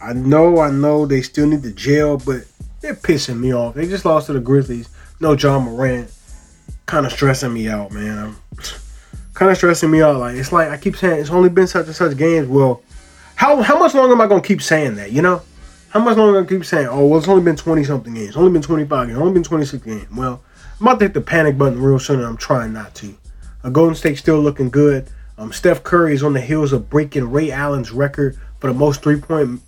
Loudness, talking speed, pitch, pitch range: -15 LUFS, 255 wpm, 145 Hz, 125-165 Hz